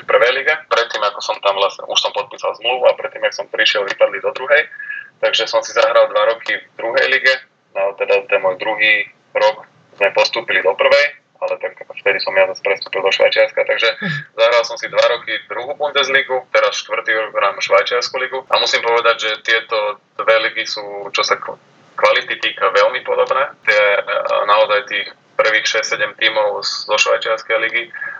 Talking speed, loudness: 185 wpm, -16 LUFS